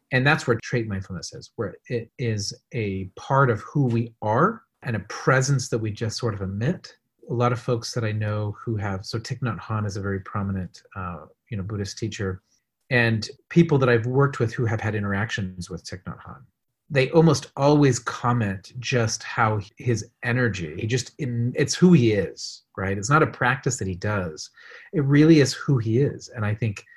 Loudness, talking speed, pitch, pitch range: -24 LUFS, 200 wpm, 115 Hz, 105-130 Hz